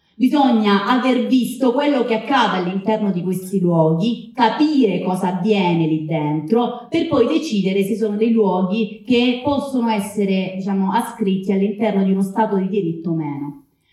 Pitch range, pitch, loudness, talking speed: 185-240 Hz, 210 Hz, -18 LUFS, 150 wpm